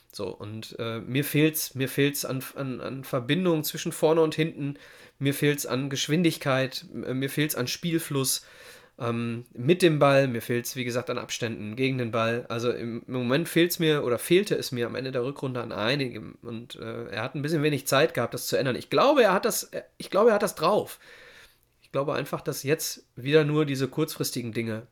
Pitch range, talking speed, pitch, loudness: 120-155 Hz, 205 wpm, 135 Hz, -26 LUFS